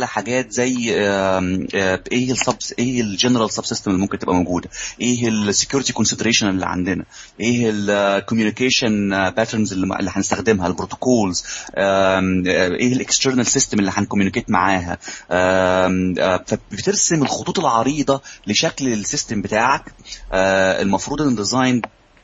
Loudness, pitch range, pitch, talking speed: -18 LUFS, 95-125 Hz, 110 Hz, 105 wpm